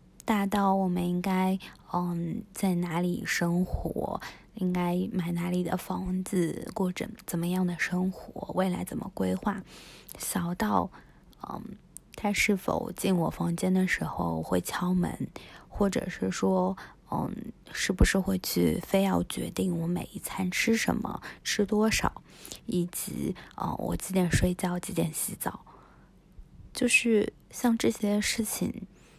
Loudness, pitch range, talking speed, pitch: -29 LUFS, 175-200 Hz, 190 characters per minute, 185 Hz